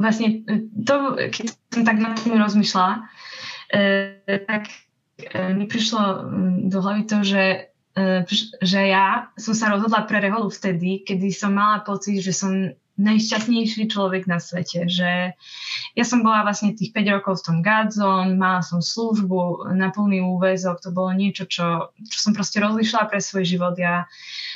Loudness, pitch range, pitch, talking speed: -21 LUFS, 185-215 Hz, 200 Hz, 155 wpm